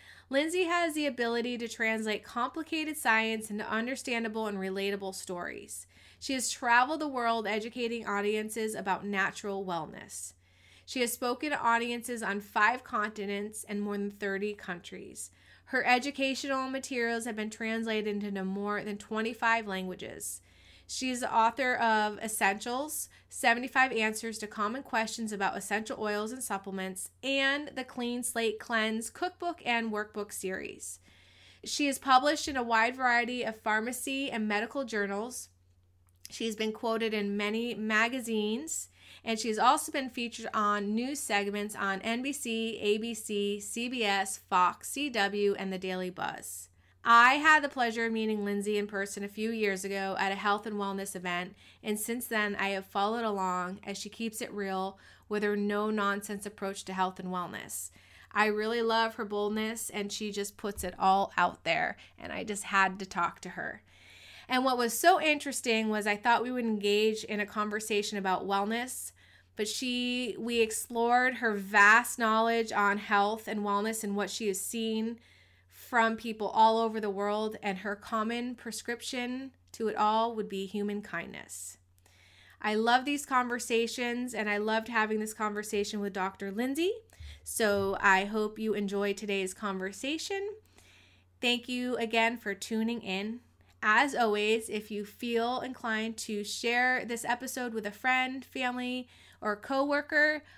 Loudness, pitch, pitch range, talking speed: -31 LUFS, 215 Hz, 200-240 Hz, 155 wpm